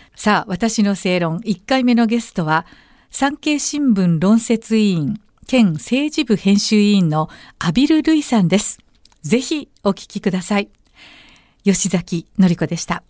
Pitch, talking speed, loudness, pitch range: 205 Hz, 255 characters per minute, -17 LUFS, 185-240 Hz